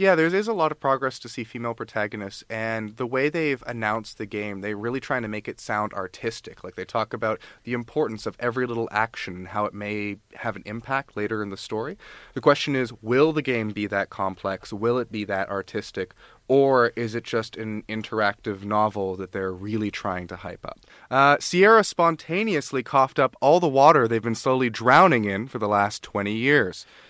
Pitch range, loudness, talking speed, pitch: 105-130 Hz, -24 LUFS, 205 wpm, 115 Hz